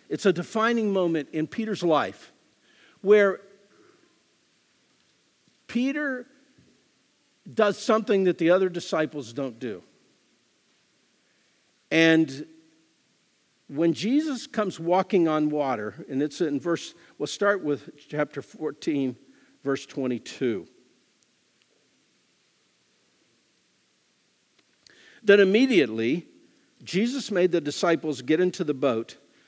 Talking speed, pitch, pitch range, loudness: 90 wpm, 170 Hz, 150-205 Hz, -25 LUFS